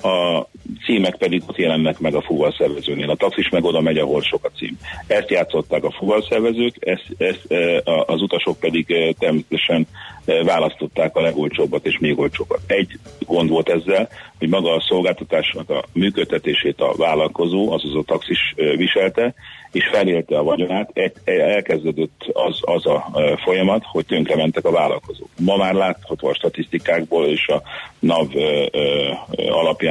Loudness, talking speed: -19 LUFS, 165 wpm